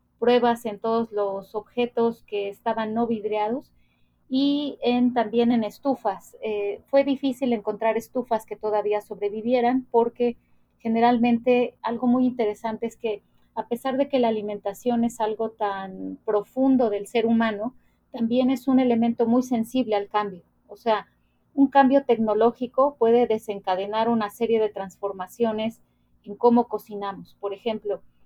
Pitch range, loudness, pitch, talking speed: 210-245 Hz, -24 LUFS, 230 Hz, 140 wpm